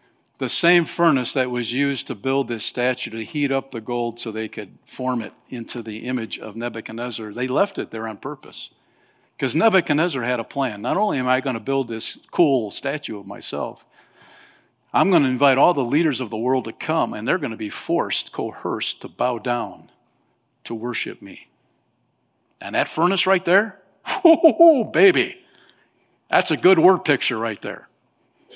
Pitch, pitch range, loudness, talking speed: 130 Hz, 115-150 Hz, -21 LUFS, 185 wpm